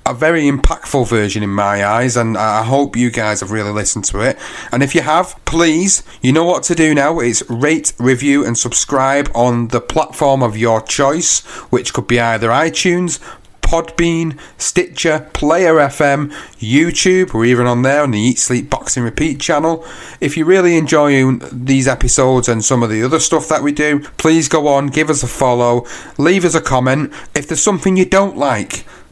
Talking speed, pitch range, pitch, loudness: 190 wpm, 120-160 Hz, 140 Hz, -14 LUFS